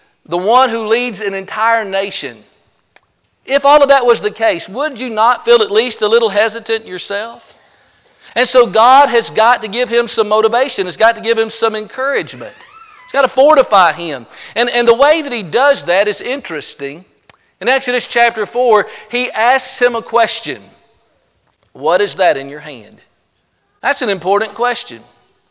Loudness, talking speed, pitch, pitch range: -12 LUFS, 175 wpm, 230 Hz, 205-255 Hz